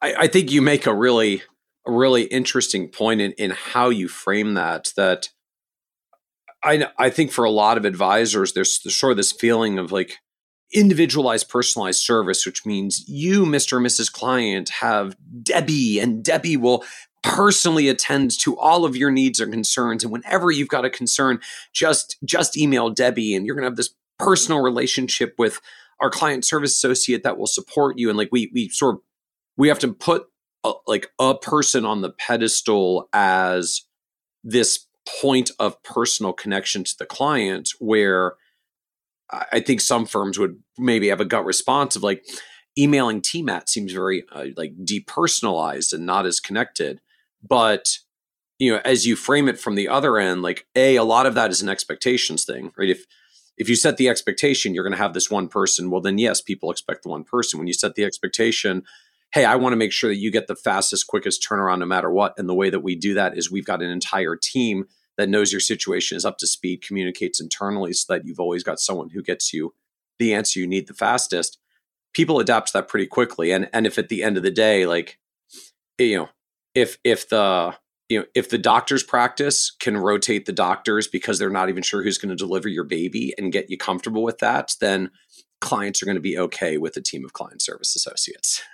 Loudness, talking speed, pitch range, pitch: -20 LUFS, 200 wpm, 100-135 Hz, 120 Hz